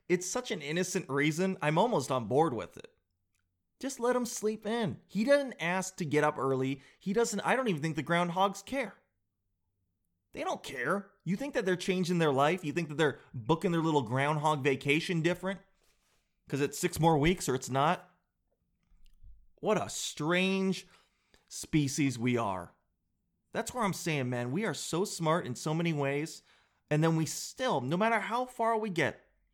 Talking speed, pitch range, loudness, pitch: 180 wpm, 135-190 Hz, -31 LUFS, 165 Hz